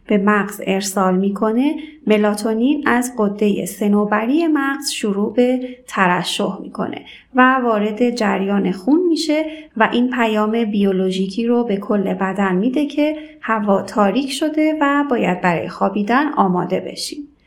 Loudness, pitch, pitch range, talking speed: -18 LUFS, 220 Hz, 200-275 Hz, 125 wpm